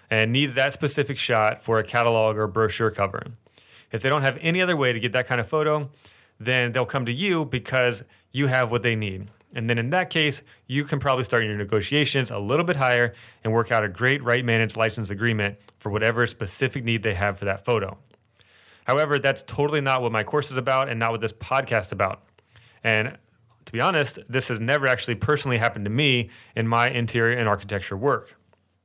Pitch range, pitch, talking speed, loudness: 110-135 Hz, 120 Hz, 210 wpm, -23 LUFS